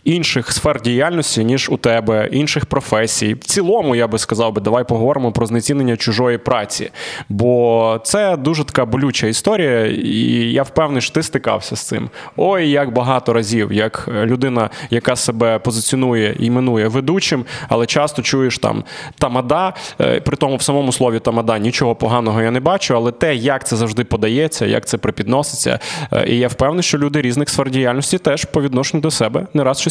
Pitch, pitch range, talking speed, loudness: 125 Hz, 115-145 Hz, 170 wpm, -16 LUFS